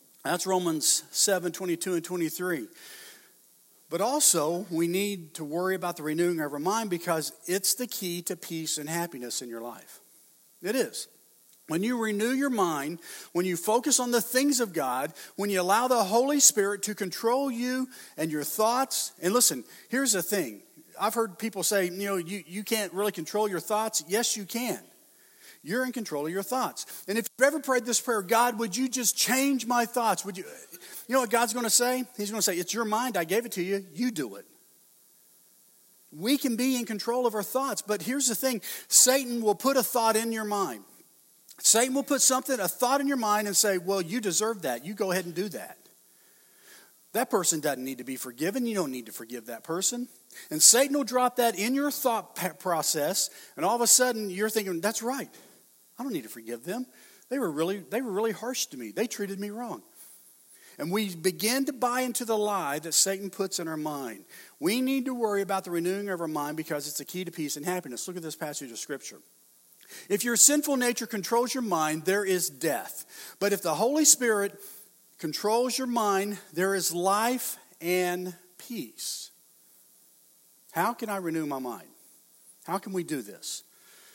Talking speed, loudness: 205 wpm, -27 LUFS